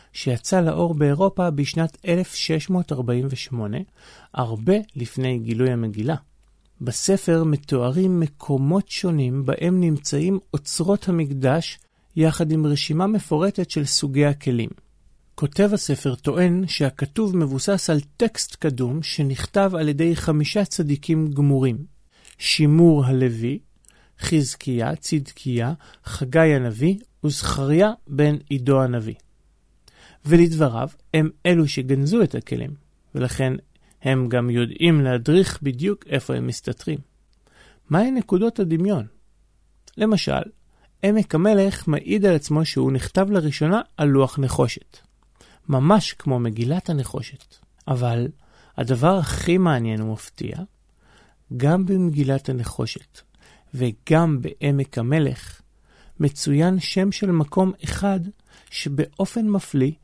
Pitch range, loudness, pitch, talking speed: 130-175 Hz, -21 LUFS, 150 Hz, 100 wpm